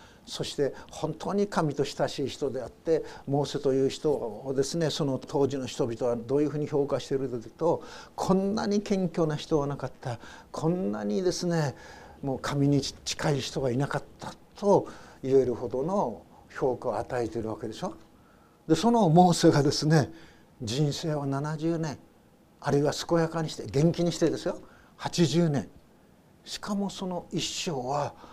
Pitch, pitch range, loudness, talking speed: 145 Hz, 135-165 Hz, -28 LUFS, 305 characters per minute